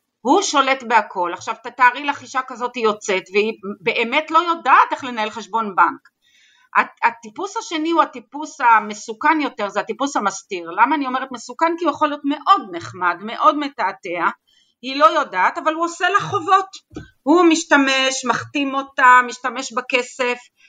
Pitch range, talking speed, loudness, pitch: 230-310 Hz, 155 wpm, -18 LUFS, 265 Hz